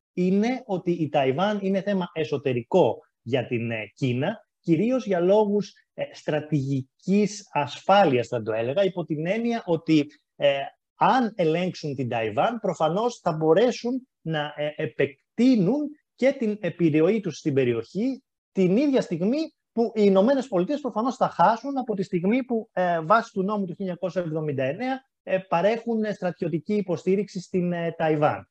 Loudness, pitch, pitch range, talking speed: -25 LUFS, 185 Hz, 155-215 Hz, 135 wpm